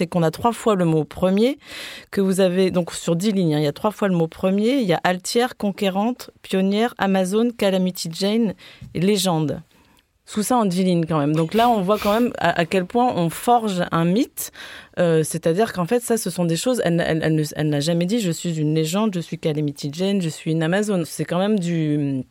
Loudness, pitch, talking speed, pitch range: -21 LUFS, 185 Hz, 240 wpm, 165-215 Hz